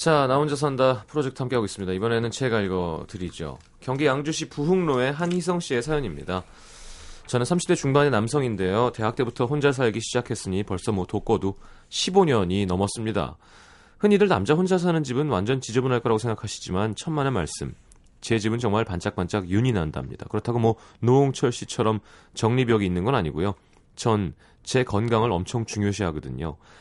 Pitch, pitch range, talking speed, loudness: 115 Hz, 100-135 Hz, 375 characters per minute, -24 LUFS